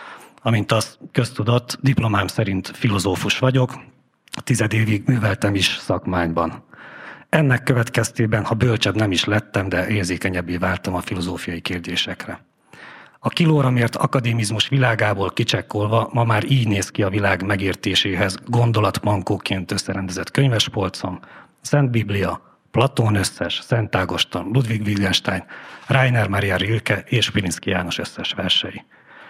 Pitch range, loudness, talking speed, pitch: 95-120 Hz, -20 LUFS, 120 wpm, 105 Hz